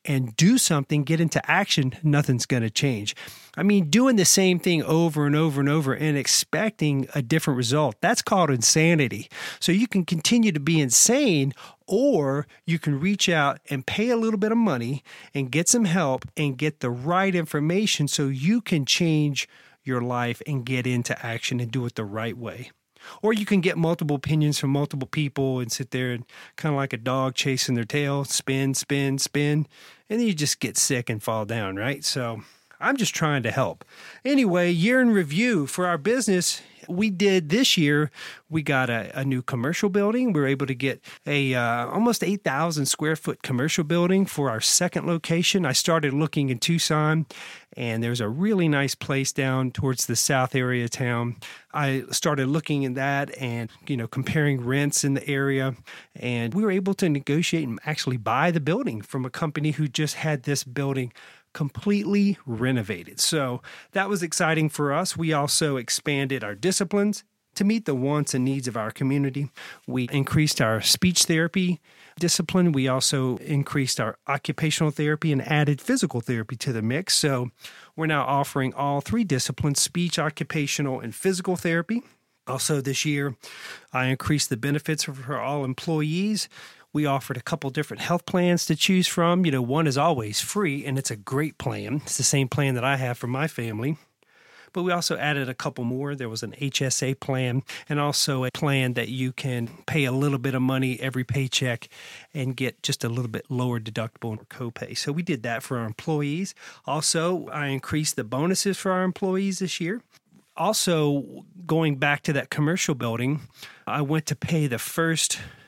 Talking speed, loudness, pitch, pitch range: 185 wpm, -24 LUFS, 145 Hz, 130-170 Hz